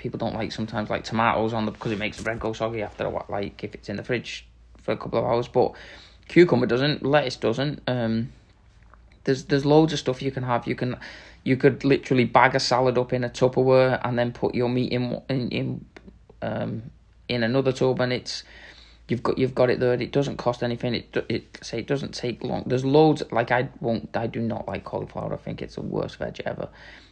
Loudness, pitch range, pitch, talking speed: -24 LUFS, 110-130 Hz, 120 Hz, 230 wpm